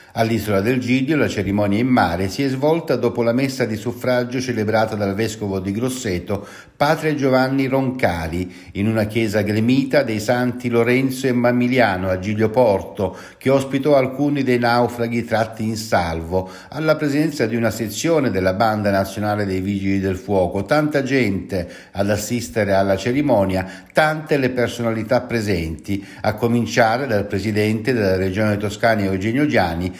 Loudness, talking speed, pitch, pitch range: -19 LUFS, 150 wpm, 110 Hz, 100-125 Hz